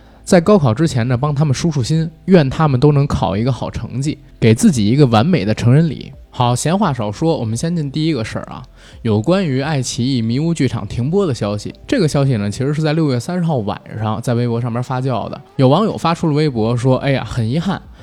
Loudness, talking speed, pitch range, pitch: -16 LUFS, 340 characters per minute, 115-160 Hz, 130 Hz